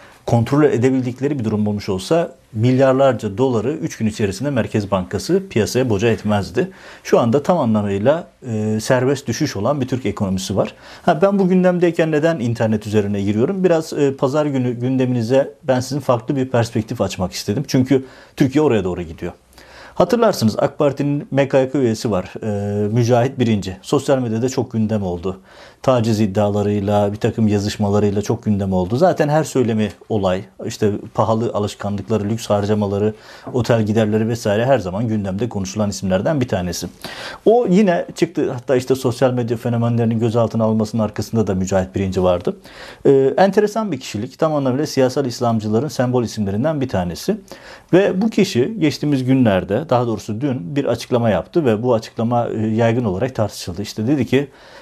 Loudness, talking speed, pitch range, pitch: -18 LUFS, 155 wpm, 105-135 Hz, 115 Hz